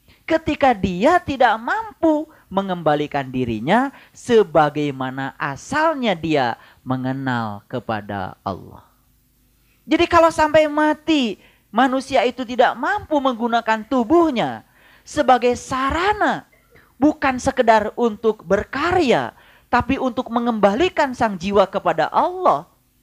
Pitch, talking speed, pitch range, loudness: 245 Hz, 90 wpm, 180-300 Hz, -19 LUFS